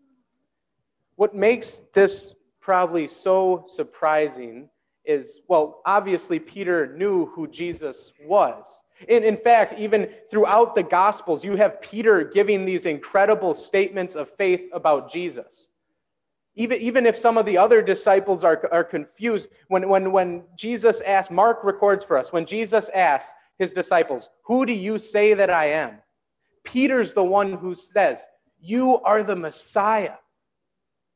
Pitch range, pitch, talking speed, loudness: 185-235 Hz, 205 Hz, 140 wpm, -21 LUFS